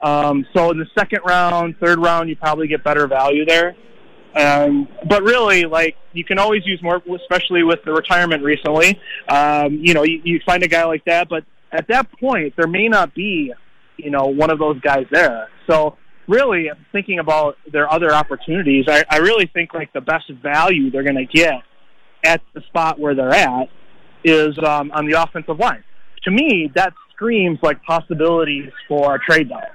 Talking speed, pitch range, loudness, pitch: 190 wpm, 150-175 Hz, -16 LUFS, 160 Hz